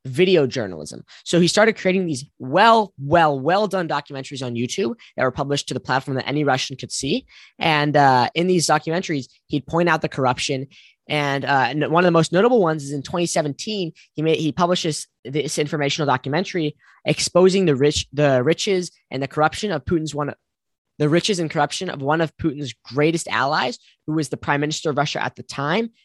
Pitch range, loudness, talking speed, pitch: 140-170 Hz, -20 LUFS, 195 wpm, 150 Hz